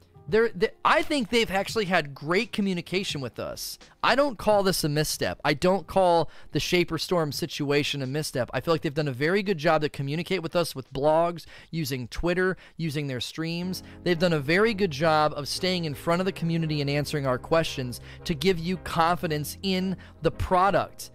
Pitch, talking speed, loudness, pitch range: 165 Hz, 200 wpm, -26 LUFS, 150-185 Hz